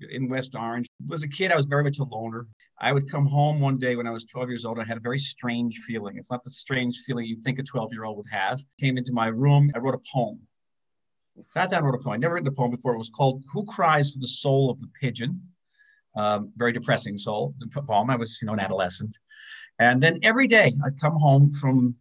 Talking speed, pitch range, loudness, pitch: 265 wpm, 120-145 Hz, -25 LUFS, 130 Hz